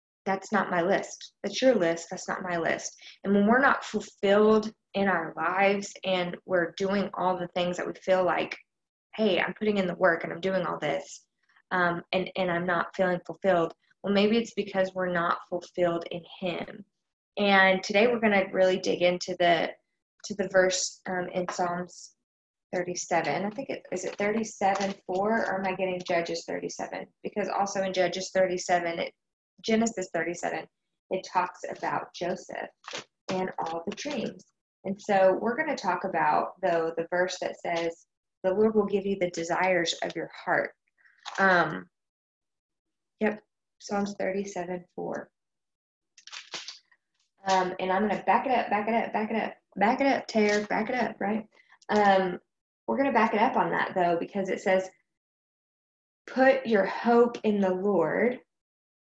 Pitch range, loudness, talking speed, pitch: 180-205 Hz, -27 LUFS, 175 wpm, 190 Hz